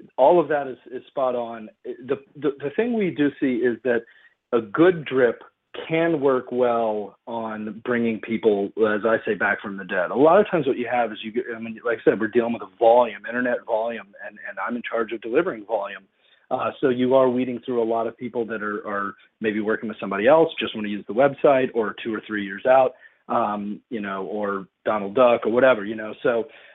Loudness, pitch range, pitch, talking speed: -23 LUFS, 110-130 Hz, 115 Hz, 230 wpm